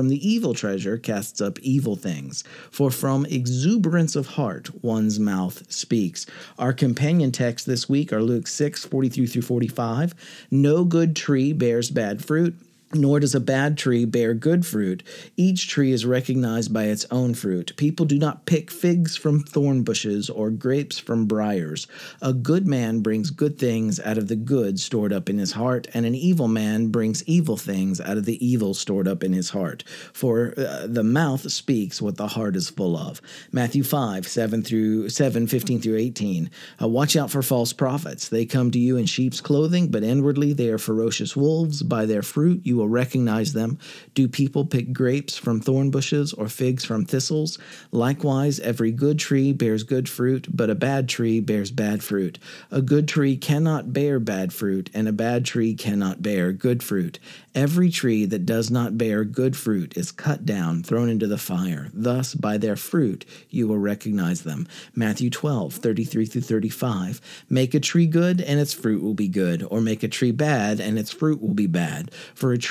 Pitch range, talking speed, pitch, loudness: 110-145 Hz, 190 wpm, 125 Hz, -23 LUFS